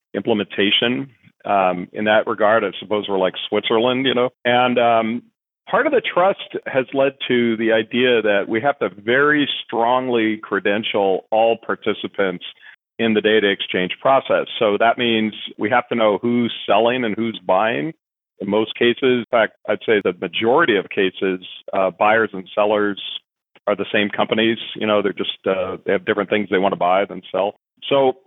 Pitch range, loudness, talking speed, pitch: 105-125 Hz, -19 LUFS, 180 wpm, 115 Hz